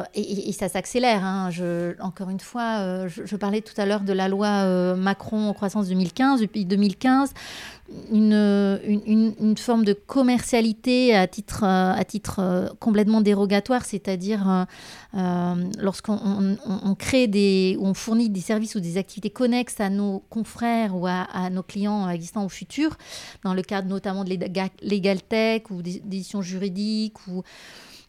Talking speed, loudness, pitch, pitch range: 170 wpm, -23 LUFS, 200 Hz, 190-215 Hz